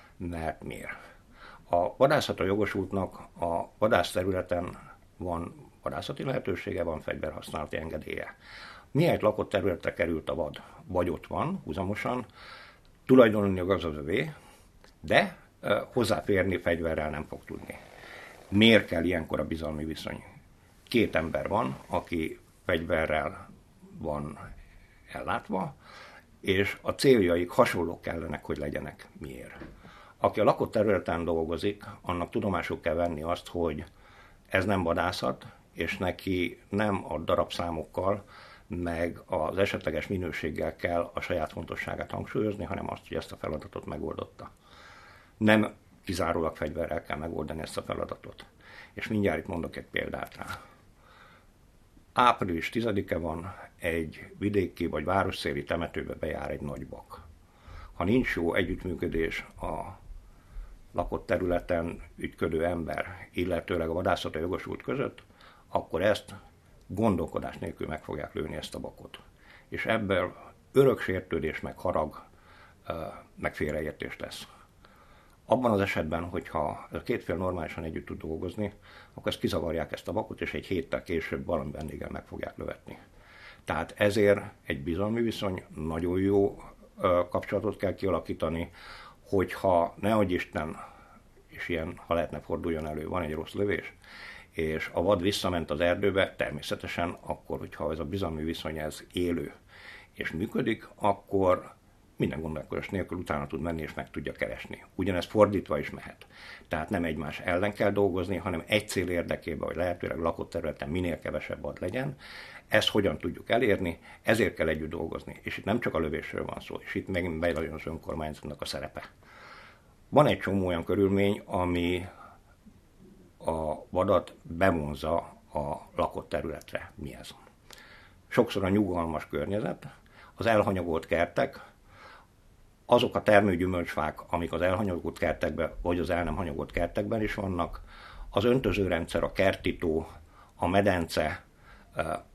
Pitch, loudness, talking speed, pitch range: 90 Hz, -30 LUFS, 130 wpm, 80-100 Hz